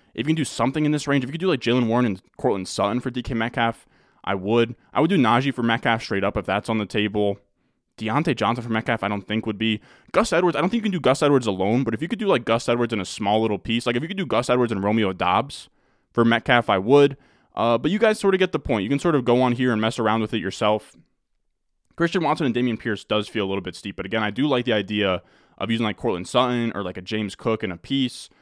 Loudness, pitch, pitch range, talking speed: -22 LUFS, 115 Hz, 105-130 Hz, 285 wpm